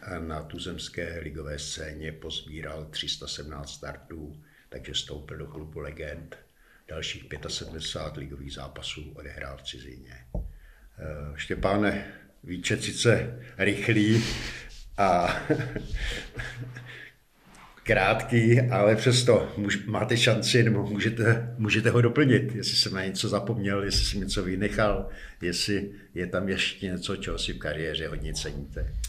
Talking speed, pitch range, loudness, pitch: 115 wpm, 75-105 Hz, -27 LUFS, 90 Hz